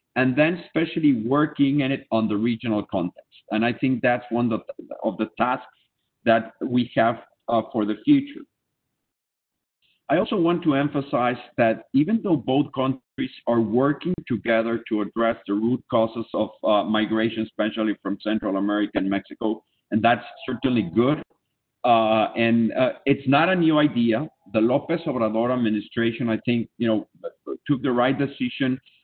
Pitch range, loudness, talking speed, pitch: 110-140 Hz, -23 LUFS, 160 wpm, 120 Hz